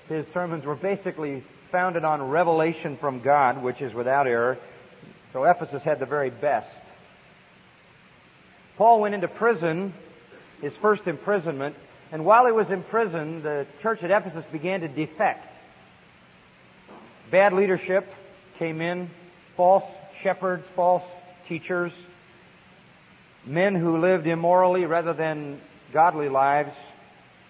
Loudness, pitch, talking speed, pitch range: -24 LUFS, 175 Hz, 120 wpm, 155-185 Hz